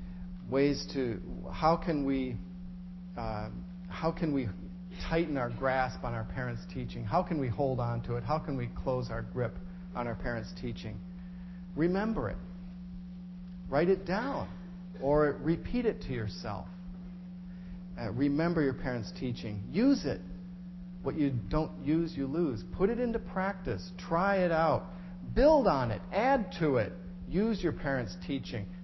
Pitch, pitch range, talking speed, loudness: 165 Hz, 130-180 Hz, 150 wpm, -32 LUFS